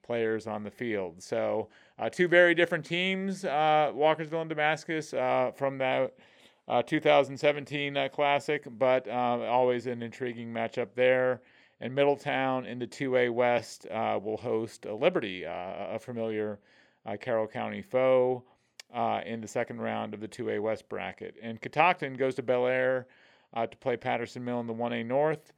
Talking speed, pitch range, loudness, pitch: 165 wpm, 115-145 Hz, -29 LUFS, 125 Hz